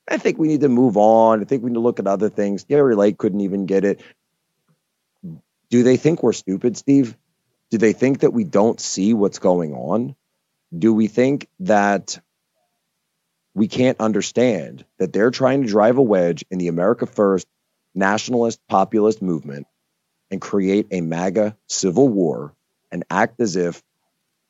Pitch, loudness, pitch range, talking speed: 110 Hz, -18 LUFS, 95-125 Hz, 170 wpm